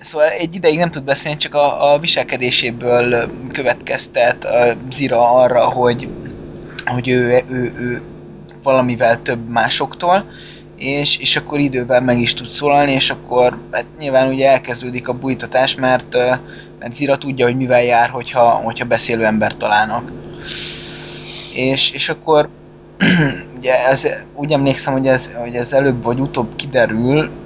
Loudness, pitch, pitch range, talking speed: -15 LUFS, 130 Hz, 120-140 Hz, 145 wpm